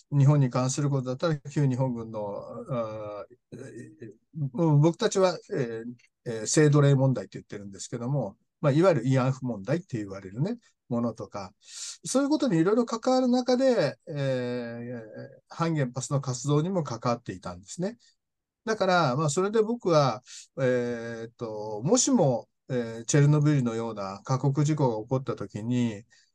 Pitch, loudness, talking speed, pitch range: 135 Hz, -27 LUFS, 330 characters per minute, 120-165 Hz